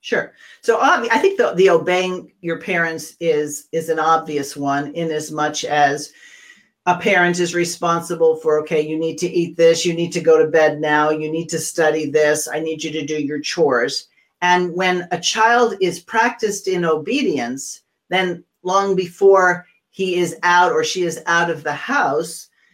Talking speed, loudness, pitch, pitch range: 185 wpm, -18 LUFS, 170 Hz, 155-180 Hz